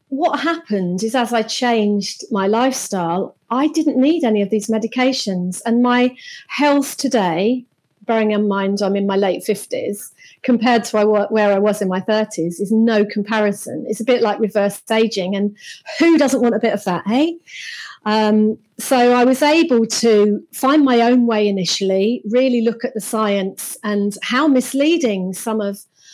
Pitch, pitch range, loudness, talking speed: 225 Hz, 205-255 Hz, -17 LUFS, 170 wpm